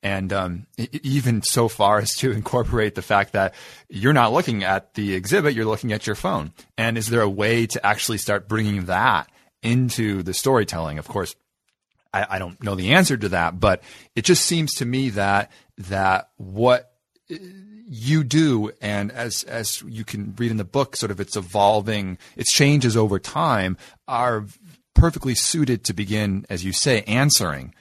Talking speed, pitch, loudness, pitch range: 175 wpm, 110 Hz, -21 LUFS, 100-125 Hz